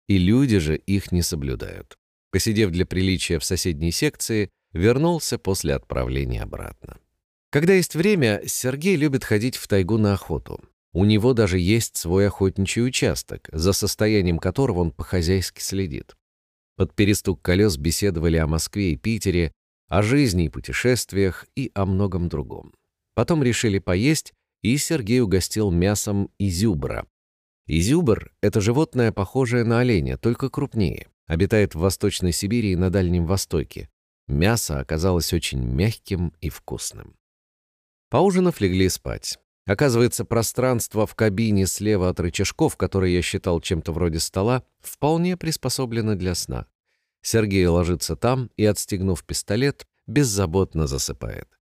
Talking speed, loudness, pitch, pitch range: 130 wpm, -22 LUFS, 100 Hz, 85-115 Hz